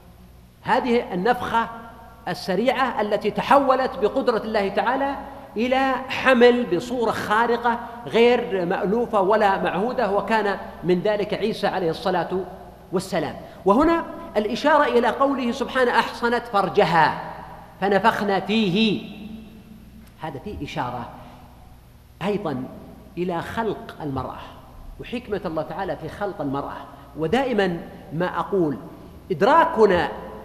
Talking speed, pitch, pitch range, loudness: 95 wpm, 210 Hz, 185-235 Hz, -22 LUFS